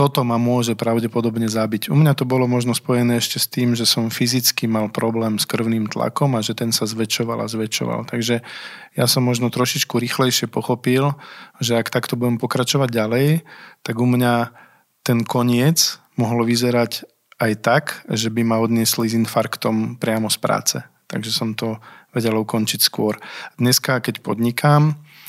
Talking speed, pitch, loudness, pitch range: 165 wpm, 120 Hz, -19 LUFS, 115-125 Hz